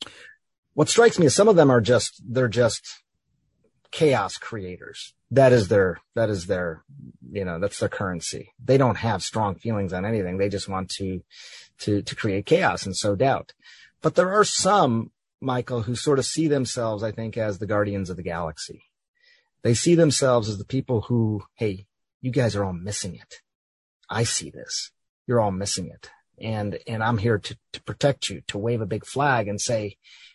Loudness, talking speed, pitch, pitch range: -23 LUFS, 190 wpm, 115 Hz, 100-130 Hz